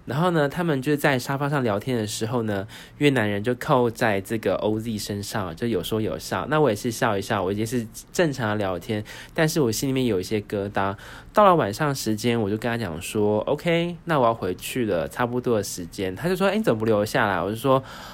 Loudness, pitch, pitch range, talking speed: -24 LUFS, 115 Hz, 105-135 Hz, 330 characters per minute